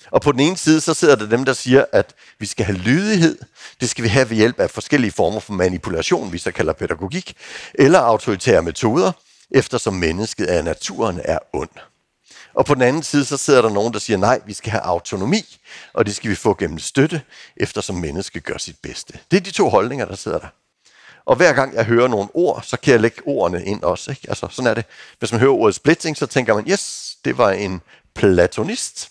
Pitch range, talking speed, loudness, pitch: 105-145 Hz, 225 wpm, -18 LUFS, 125 Hz